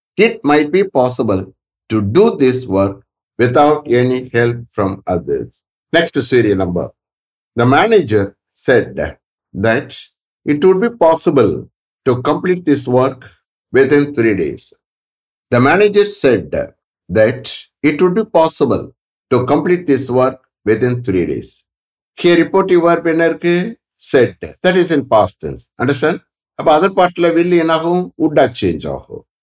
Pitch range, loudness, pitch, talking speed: 125-175 Hz, -14 LUFS, 150 Hz, 120 wpm